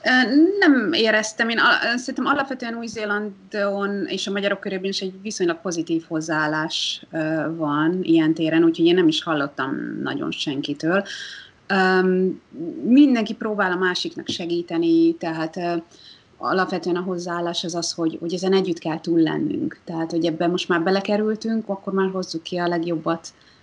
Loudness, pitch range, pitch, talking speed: -21 LUFS, 165-215 Hz, 185 Hz, 140 wpm